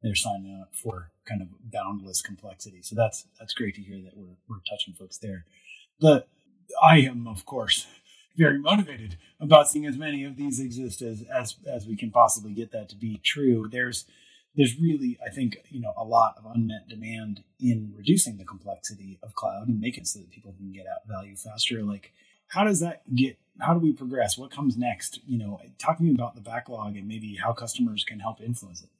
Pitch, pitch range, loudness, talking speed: 115 Hz, 100-130 Hz, -26 LUFS, 210 wpm